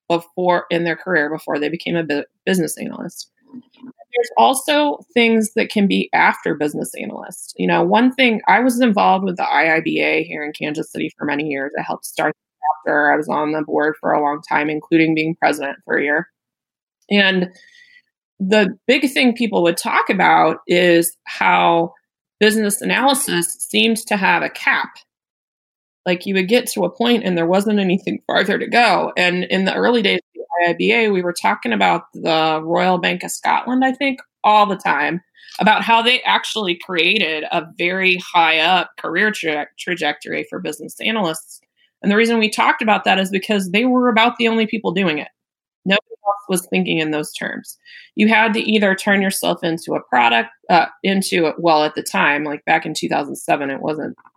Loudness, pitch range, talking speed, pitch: -17 LUFS, 165-225 Hz, 185 wpm, 190 Hz